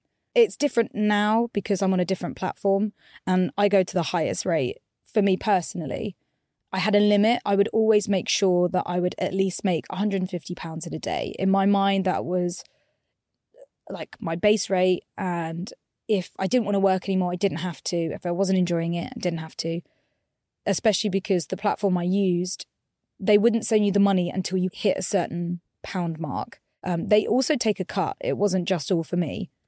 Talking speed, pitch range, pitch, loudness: 200 wpm, 180-205 Hz, 190 Hz, -24 LUFS